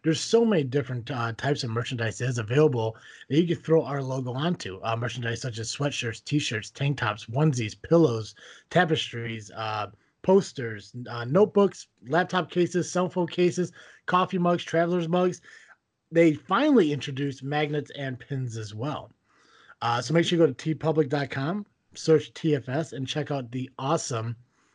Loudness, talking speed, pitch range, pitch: -26 LUFS, 160 wpm, 120-165 Hz, 145 Hz